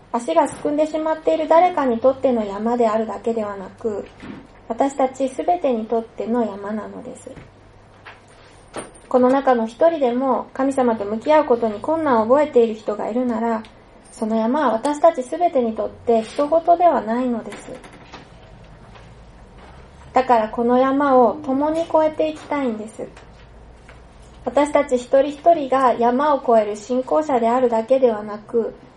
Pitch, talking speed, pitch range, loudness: 250 Hz, 300 characters per minute, 225-285 Hz, -19 LUFS